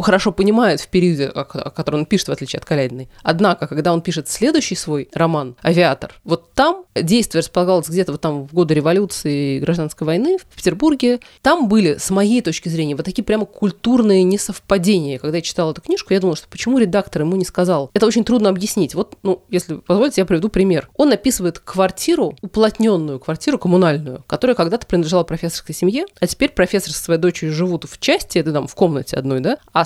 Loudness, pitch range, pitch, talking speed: -17 LUFS, 160-210 Hz, 180 Hz, 195 wpm